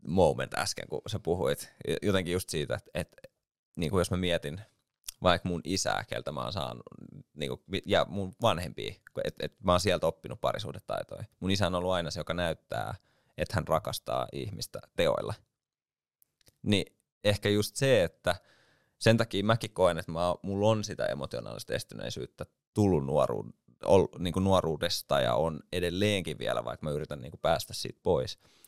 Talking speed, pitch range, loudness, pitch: 155 wpm, 85-105 Hz, -31 LUFS, 90 Hz